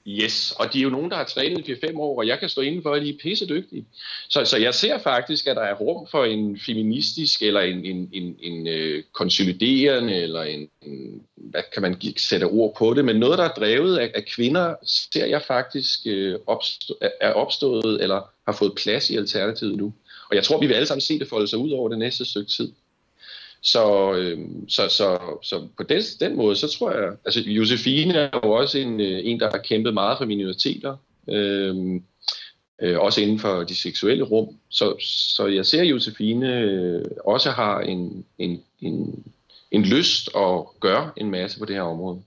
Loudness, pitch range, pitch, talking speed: -22 LUFS, 95-125 Hz, 105 Hz, 200 wpm